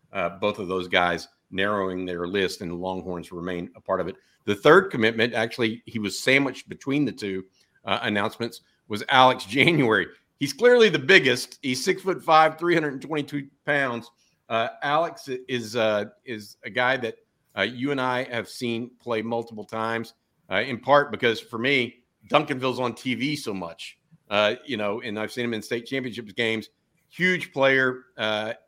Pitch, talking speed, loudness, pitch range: 120 Hz, 180 wpm, -24 LUFS, 105-140 Hz